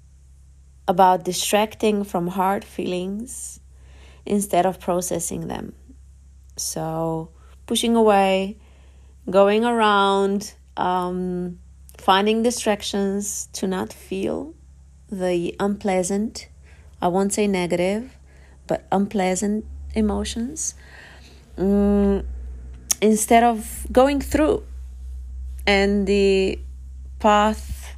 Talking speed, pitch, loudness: 80 wpm, 185 Hz, -21 LUFS